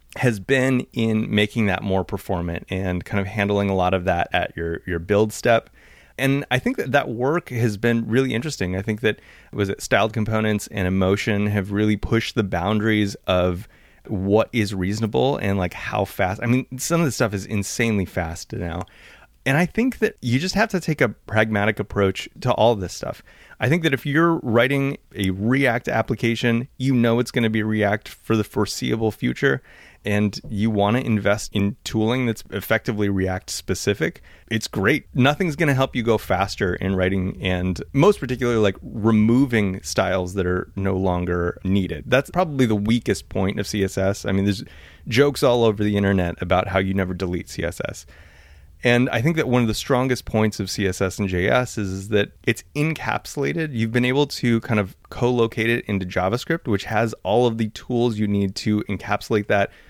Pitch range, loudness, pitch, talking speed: 95-120 Hz, -22 LUFS, 105 Hz, 195 wpm